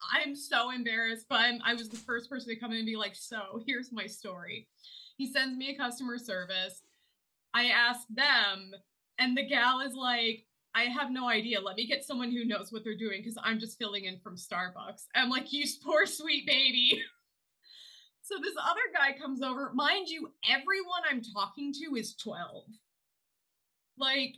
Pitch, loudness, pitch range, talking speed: 245 Hz, -31 LUFS, 220-275 Hz, 185 wpm